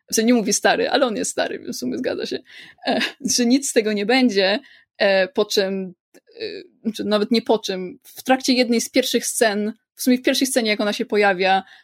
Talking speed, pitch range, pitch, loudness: 230 wpm, 205-250 Hz, 230 Hz, -20 LUFS